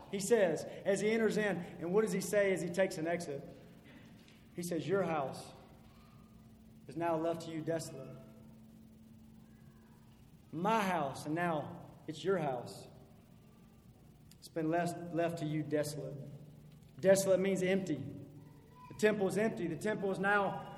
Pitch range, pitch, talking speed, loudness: 155-195 Hz, 170 Hz, 145 wpm, -35 LUFS